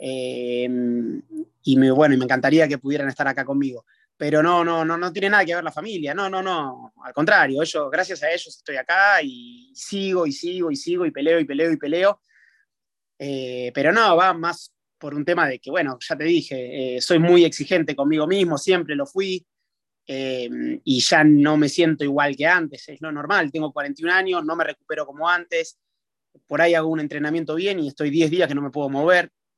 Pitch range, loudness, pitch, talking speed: 140-180 Hz, -20 LUFS, 155 Hz, 215 wpm